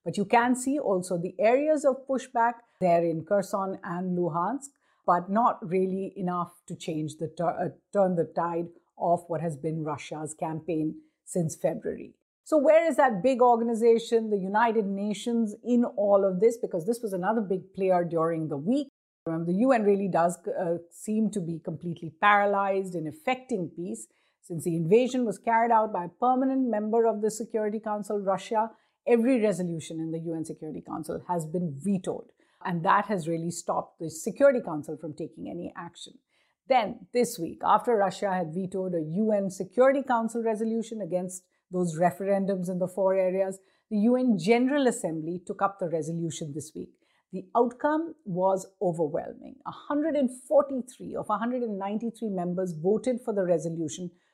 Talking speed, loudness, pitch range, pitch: 160 wpm, -27 LUFS, 175-230 Hz, 195 Hz